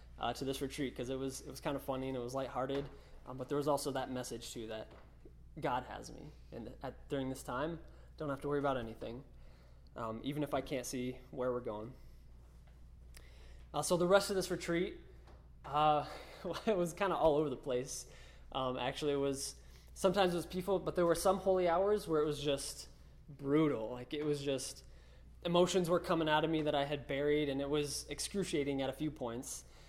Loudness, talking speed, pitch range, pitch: -37 LUFS, 215 wpm, 125-155 Hz, 140 Hz